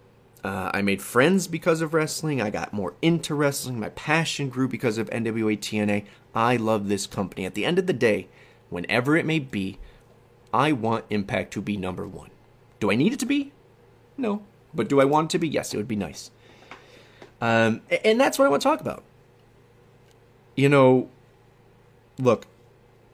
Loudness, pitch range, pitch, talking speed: -24 LUFS, 110-150 Hz, 120 Hz, 185 wpm